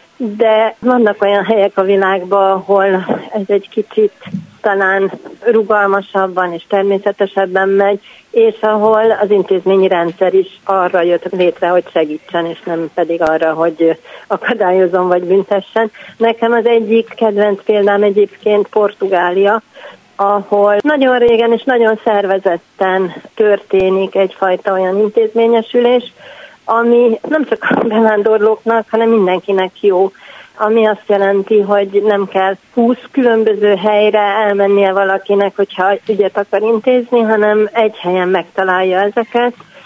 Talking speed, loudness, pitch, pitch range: 120 wpm, -13 LUFS, 200 Hz, 190-220 Hz